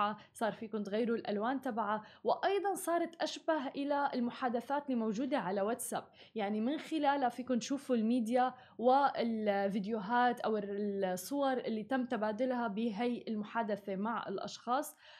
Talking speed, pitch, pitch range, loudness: 115 wpm, 240 Hz, 220-275 Hz, -35 LUFS